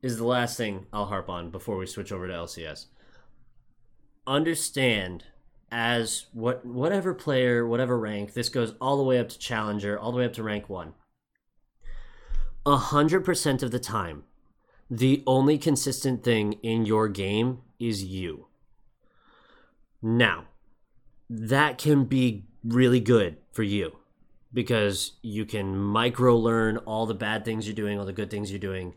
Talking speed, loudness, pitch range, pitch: 150 wpm, -26 LUFS, 105-125 Hz, 115 Hz